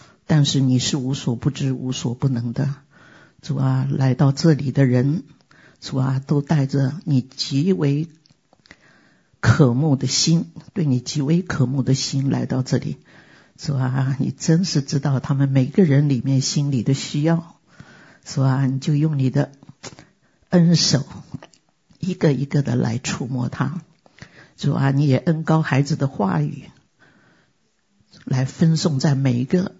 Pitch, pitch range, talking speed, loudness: 140 Hz, 135-160 Hz, 200 characters per minute, -20 LUFS